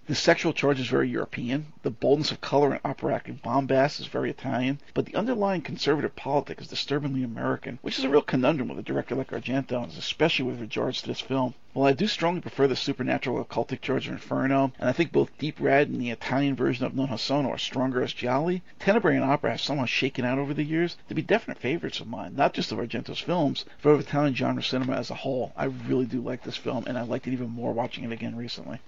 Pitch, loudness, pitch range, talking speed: 135 Hz, -27 LUFS, 125-145 Hz, 240 wpm